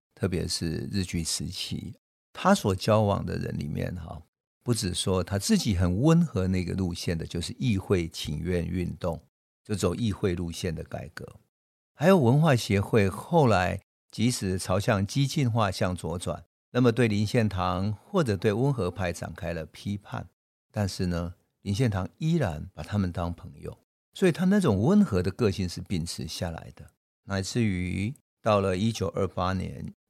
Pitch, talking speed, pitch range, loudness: 100 Hz, 245 characters per minute, 90-115 Hz, -27 LUFS